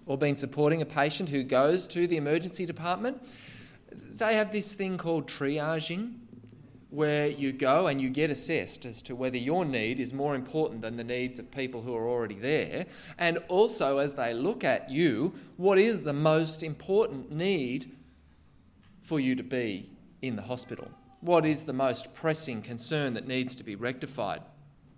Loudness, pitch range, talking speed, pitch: -30 LUFS, 125-165 Hz, 175 wpm, 145 Hz